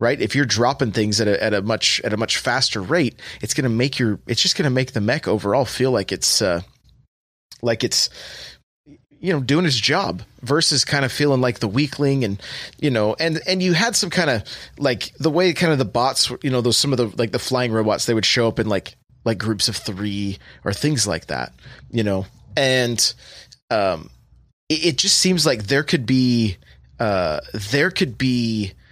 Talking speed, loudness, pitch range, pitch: 215 wpm, -19 LUFS, 105-145 Hz, 125 Hz